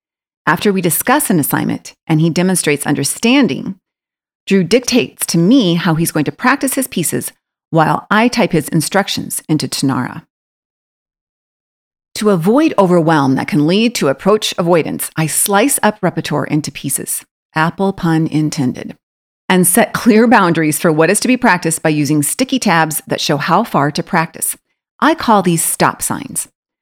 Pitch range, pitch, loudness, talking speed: 155-215 Hz, 175 Hz, -14 LUFS, 155 wpm